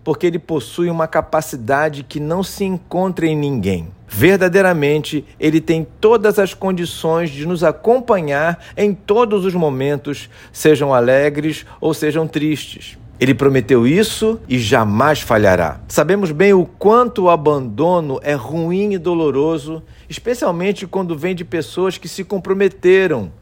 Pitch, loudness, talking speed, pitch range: 160 Hz, -16 LUFS, 135 wpm, 140-185 Hz